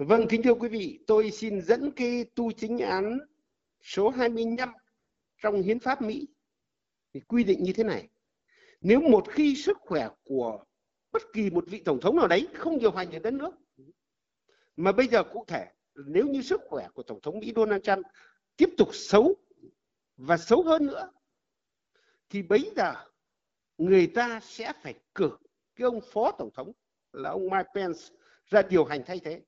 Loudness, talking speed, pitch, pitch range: -27 LUFS, 180 wpm, 230 Hz, 200-295 Hz